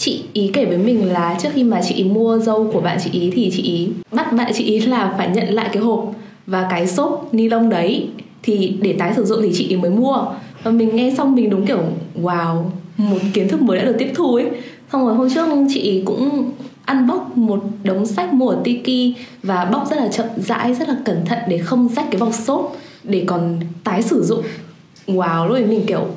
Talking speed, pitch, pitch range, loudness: 235 wpm, 220 Hz, 190-245 Hz, -17 LUFS